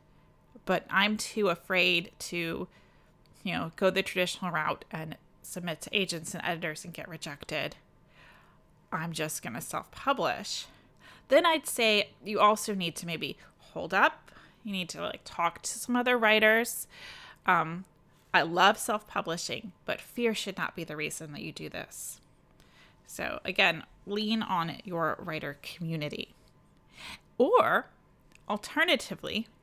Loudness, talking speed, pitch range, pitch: -30 LUFS, 135 wpm, 165-215 Hz, 185 Hz